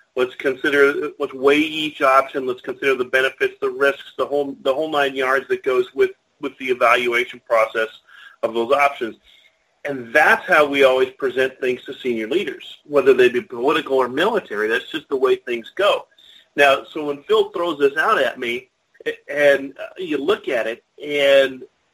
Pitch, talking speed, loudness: 145 Hz, 180 wpm, -19 LUFS